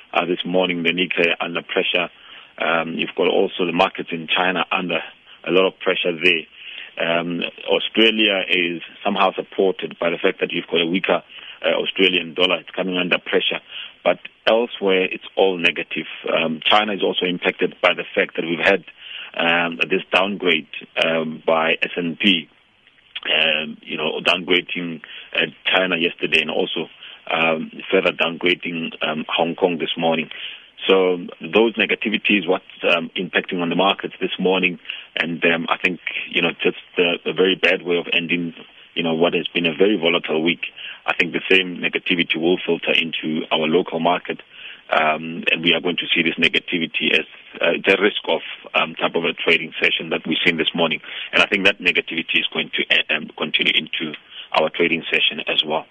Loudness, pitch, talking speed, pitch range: -19 LUFS, 85 Hz, 180 wpm, 85-95 Hz